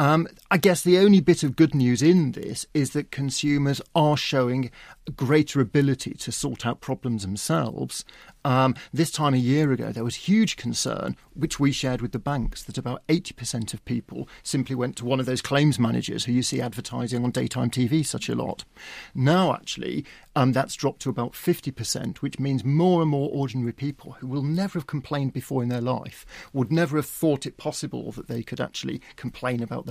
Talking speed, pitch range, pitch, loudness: 200 wpm, 125-150 Hz, 135 Hz, -25 LUFS